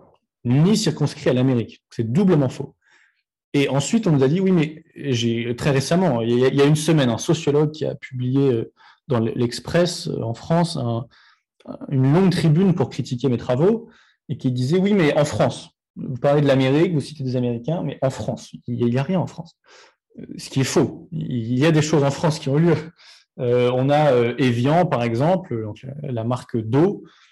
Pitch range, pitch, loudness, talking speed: 125-160 Hz, 140 Hz, -20 LUFS, 200 wpm